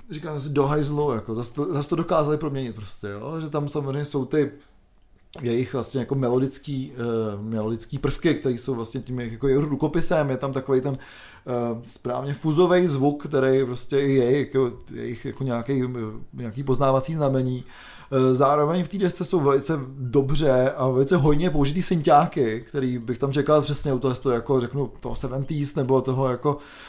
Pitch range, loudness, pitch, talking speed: 125-145 Hz, -23 LUFS, 135 Hz, 175 wpm